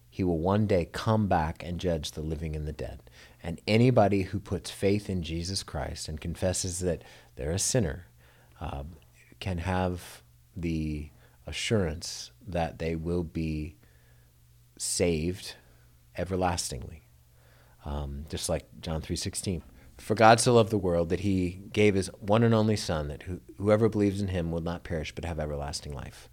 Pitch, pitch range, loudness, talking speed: 85 Hz, 70-95 Hz, -29 LUFS, 160 wpm